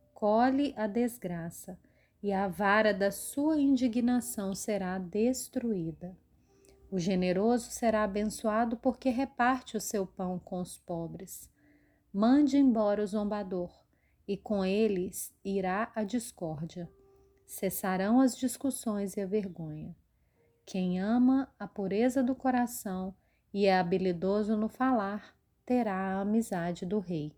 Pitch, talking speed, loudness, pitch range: 205 Hz, 120 wpm, -31 LUFS, 185-240 Hz